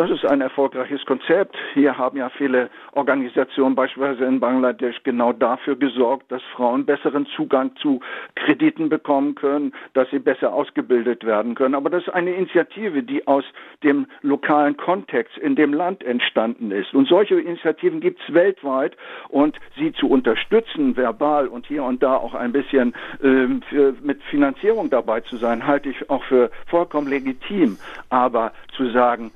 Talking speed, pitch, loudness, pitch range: 160 wpm, 140 Hz, -20 LUFS, 130-170 Hz